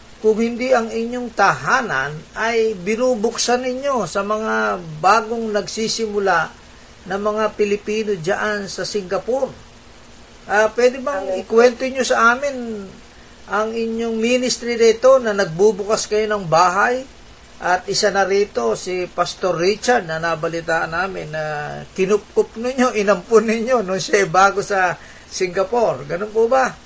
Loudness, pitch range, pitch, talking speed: -18 LUFS, 190-235 Hz, 215 Hz, 130 wpm